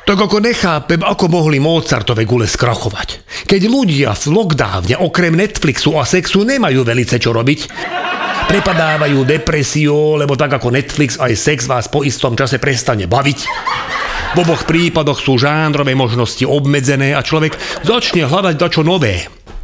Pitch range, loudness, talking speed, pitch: 130-170 Hz, -13 LUFS, 145 wpm, 150 Hz